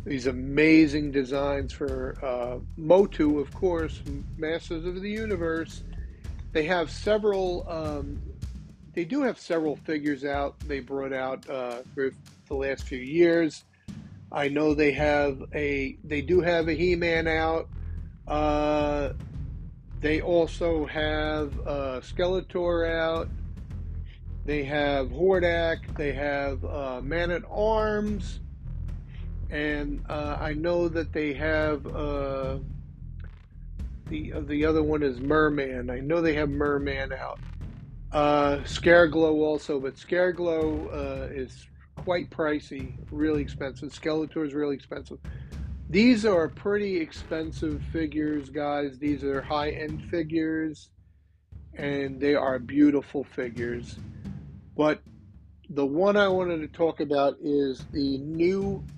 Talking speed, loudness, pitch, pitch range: 120 wpm, -27 LUFS, 150 Hz, 135-165 Hz